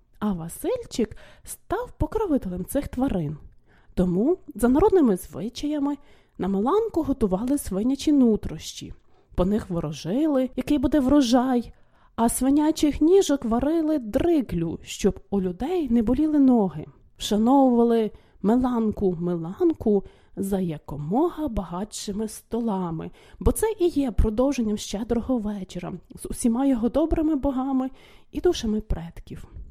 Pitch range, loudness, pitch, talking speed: 200-290 Hz, -24 LUFS, 245 Hz, 105 wpm